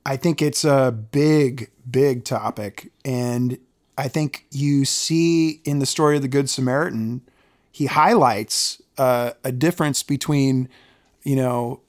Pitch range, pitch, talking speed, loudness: 125-145 Hz, 135 Hz, 135 wpm, -20 LUFS